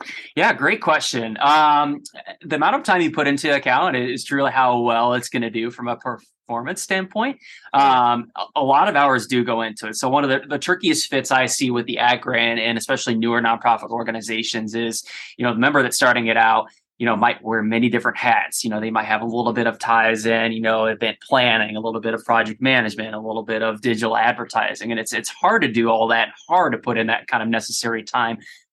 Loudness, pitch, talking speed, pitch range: -19 LUFS, 115 Hz, 235 wpm, 115-130 Hz